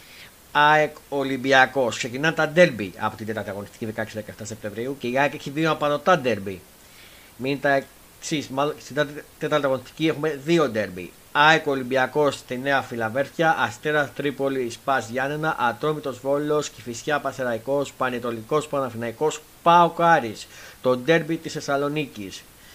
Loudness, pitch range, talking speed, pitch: -23 LUFS, 120-150 Hz, 125 wpm, 140 Hz